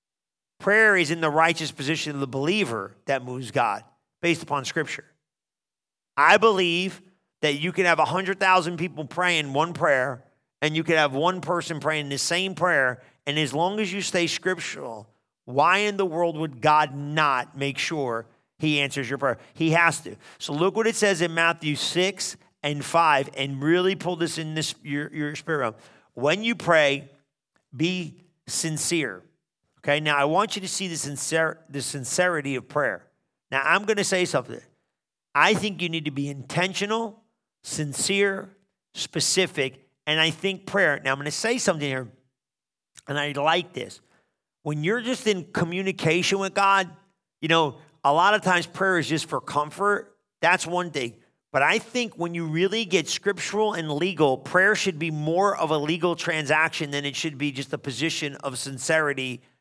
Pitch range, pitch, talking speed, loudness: 145-185 Hz, 160 Hz, 175 wpm, -24 LUFS